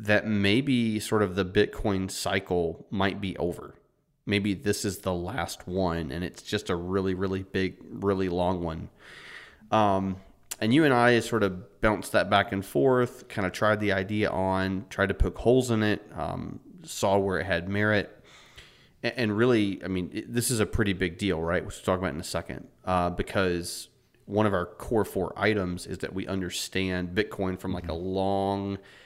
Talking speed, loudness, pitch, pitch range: 190 wpm, -27 LUFS, 95 Hz, 90-105 Hz